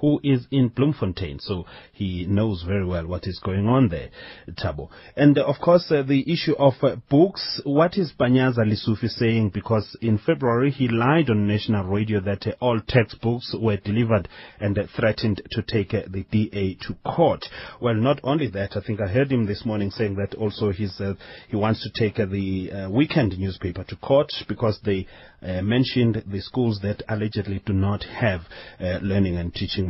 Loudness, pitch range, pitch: -23 LUFS, 100-125 Hz, 110 Hz